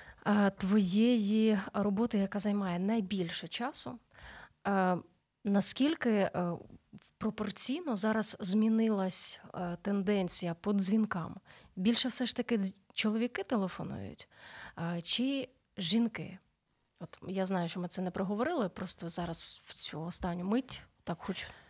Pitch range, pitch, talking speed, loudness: 185-225 Hz, 200 Hz, 100 wpm, -32 LUFS